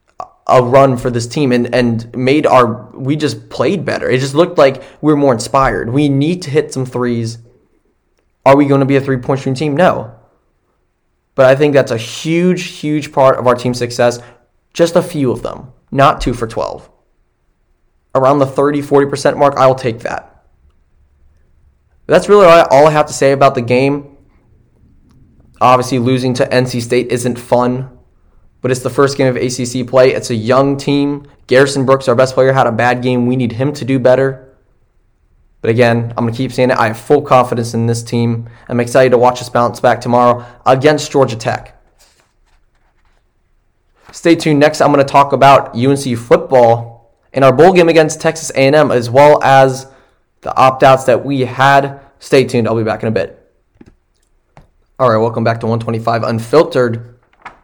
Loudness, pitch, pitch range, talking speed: -12 LUFS, 130 Hz, 120-140 Hz, 185 wpm